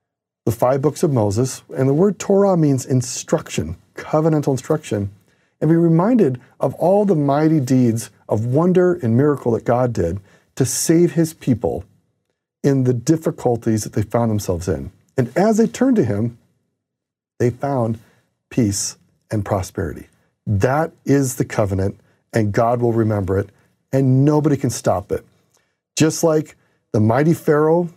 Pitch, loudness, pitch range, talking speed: 130 Hz, -18 LUFS, 115-160 Hz, 150 wpm